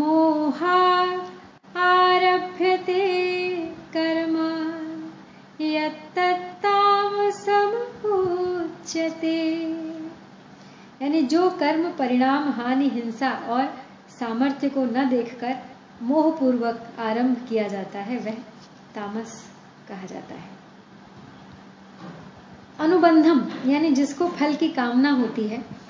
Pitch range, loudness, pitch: 245-350 Hz, -23 LUFS, 305 Hz